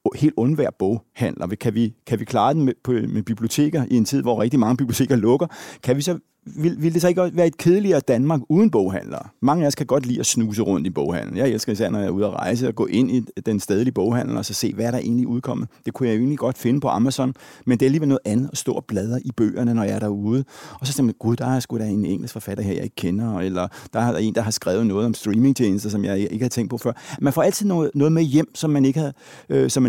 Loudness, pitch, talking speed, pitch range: -21 LUFS, 125 Hz, 275 wpm, 115-145 Hz